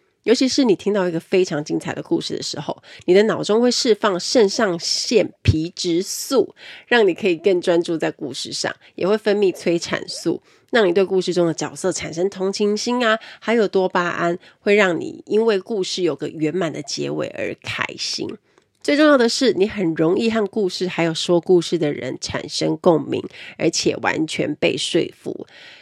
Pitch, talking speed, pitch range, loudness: 185 Hz, 270 characters per minute, 170-215 Hz, -20 LUFS